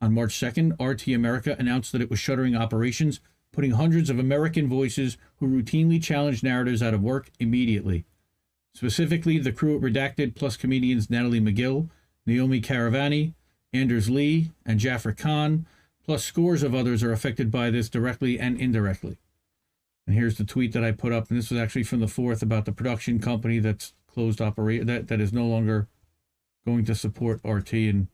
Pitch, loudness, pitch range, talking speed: 120 Hz, -25 LUFS, 110-135 Hz, 175 wpm